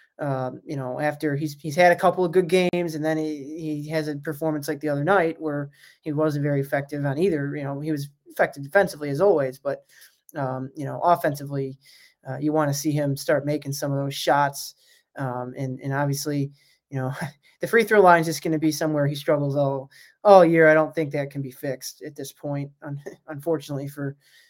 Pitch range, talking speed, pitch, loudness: 140-160 Hz, 215 wpm, 145 Hz, -23 LUFS